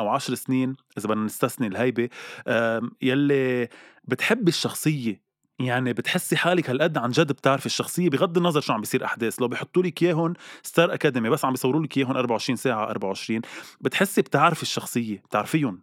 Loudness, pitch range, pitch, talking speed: -24 LUFS, 120-160 Hz, 130 Hz, 150 wpm